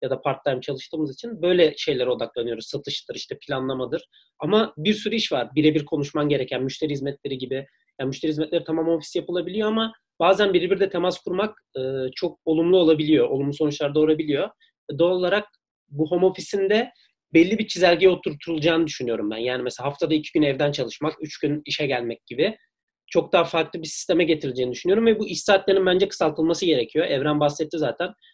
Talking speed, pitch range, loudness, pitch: 170 wpm, 145-190 Hz, -23 LUFS, 160 Hz